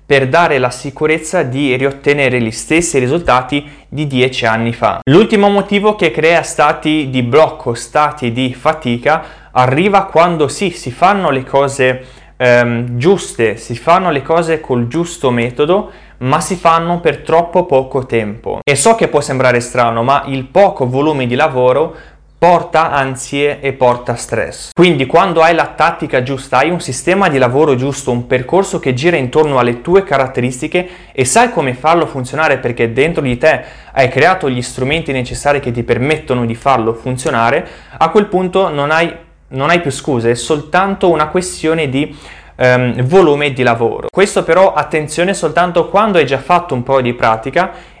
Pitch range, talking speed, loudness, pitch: 125-170 Hz, 165 wpm, -13 LUFS, 145 Hz